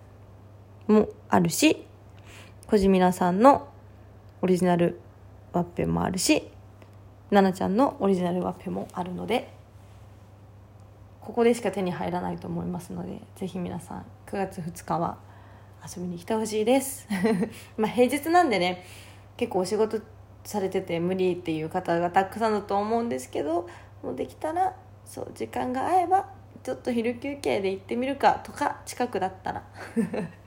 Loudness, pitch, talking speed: -26 LUFS, 180 Hz, 290 characters per minute